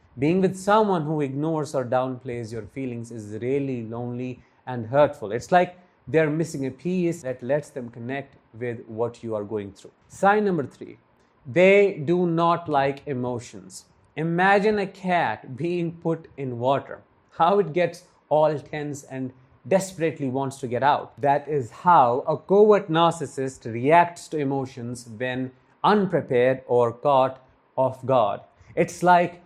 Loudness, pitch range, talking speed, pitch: -23 LUFS, 125-170 Hz, 150 wpm, 140 Hz